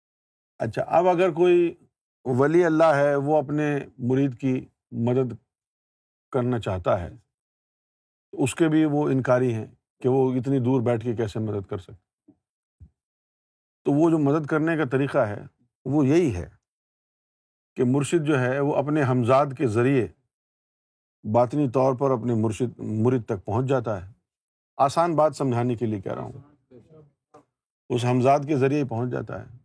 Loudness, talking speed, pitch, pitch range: -23 LUFS, 160 wpm, 130 Hz, 120-145 Hz